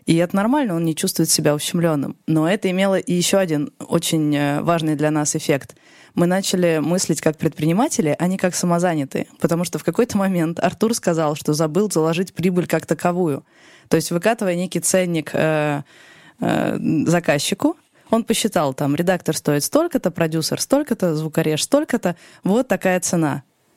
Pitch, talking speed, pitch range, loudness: 170 Hz, 150 wpm, 155-190 Hz, -20 LUFS